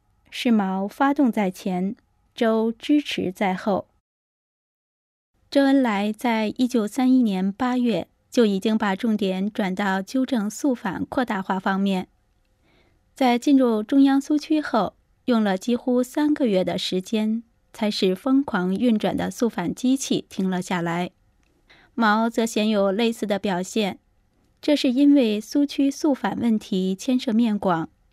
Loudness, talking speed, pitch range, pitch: -22 LUFS, 205 characters per minute, 195-255 Hz, 220 Hz